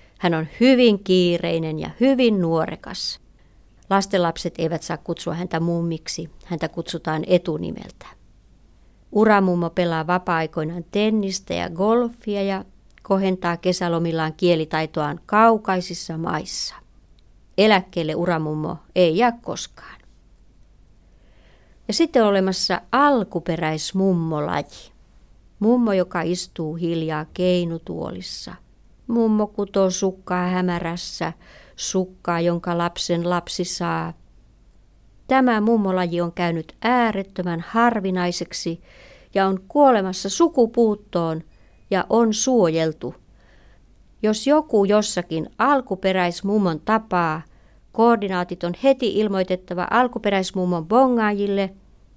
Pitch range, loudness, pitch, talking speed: 170-210 Hz, -21 LUFS, 180 Hz, 85 wpm